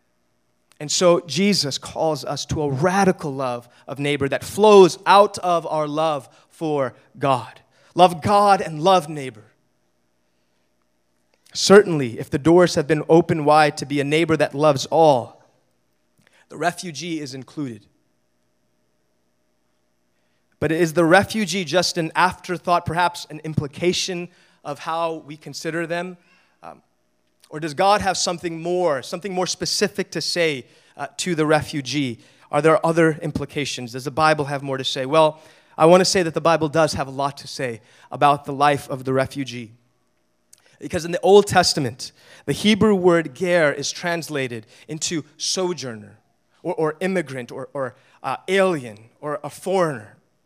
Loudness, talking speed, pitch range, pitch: -20 LUFS, 150 wpm, 130-175 Hz, 150 Hz